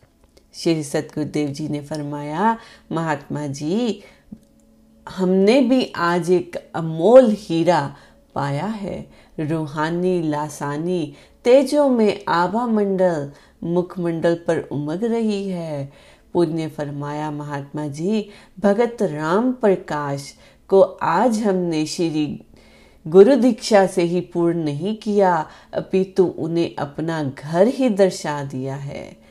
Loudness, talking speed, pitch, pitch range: -20 LUFS, 110 wpm, 170 Hz, 150-195 Hz